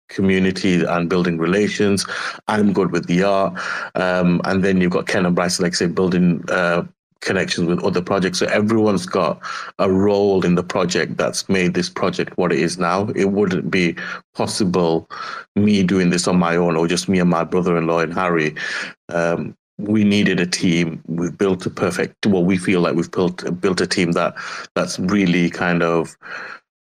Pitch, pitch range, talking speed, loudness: 90 Hz, 85-95 Hz, 185 wpm, -18 LUFS